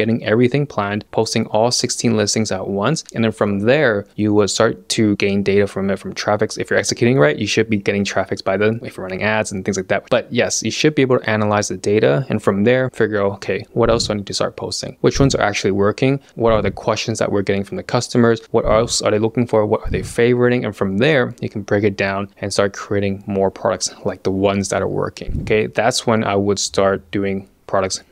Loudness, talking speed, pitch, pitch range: -18 LUFS, 250 wpm, 105 Hz, 100-115 Hz